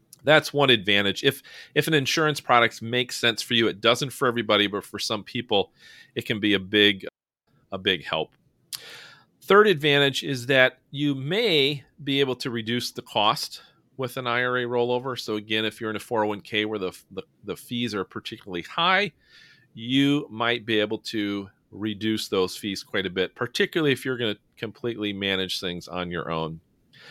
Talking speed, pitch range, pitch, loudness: 180 wpm, 105-135 Hz, 120 Hz, -24 LUFS